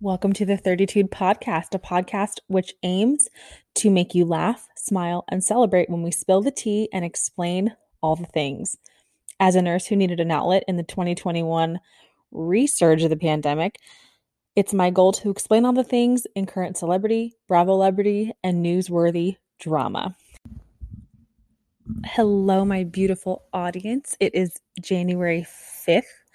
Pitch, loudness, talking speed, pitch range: 185 Hz, -22 LUFS, 145 wpm, 175-205 Hz